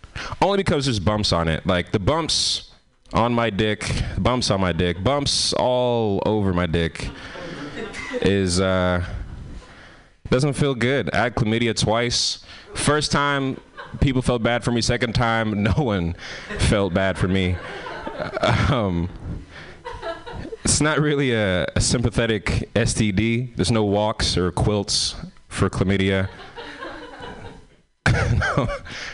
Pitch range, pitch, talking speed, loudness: 95-125 Hz, 110 Hz, 130 wpm, -21 LUFS